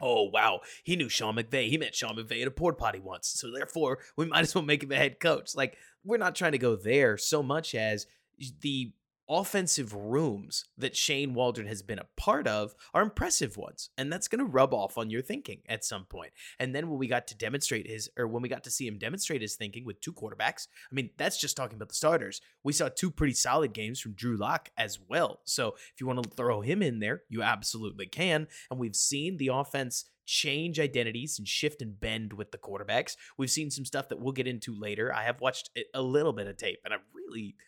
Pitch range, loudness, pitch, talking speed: 115-150 Hz, -31 LUFS, 130 Hz, 235 wpm